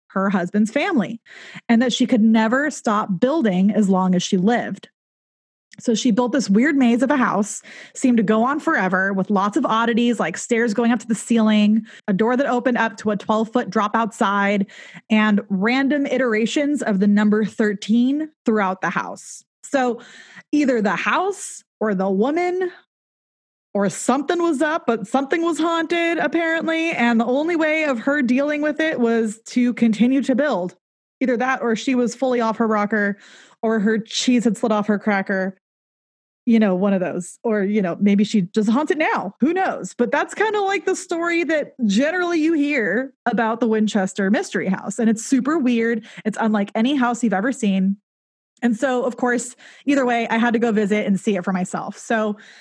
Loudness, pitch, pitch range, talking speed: -20 LUFS, 230 Hz, 210-270 Hz, 190 wpm